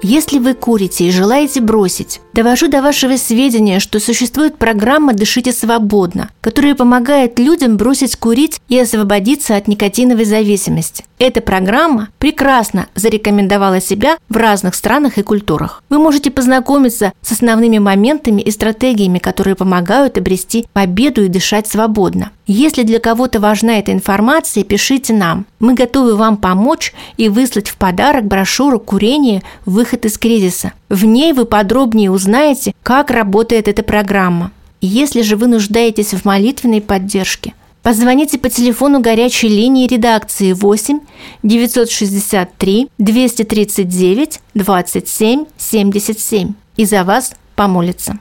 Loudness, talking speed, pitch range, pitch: -12 LUFS, 125 wpm, 200-255 Hz, 225 Hz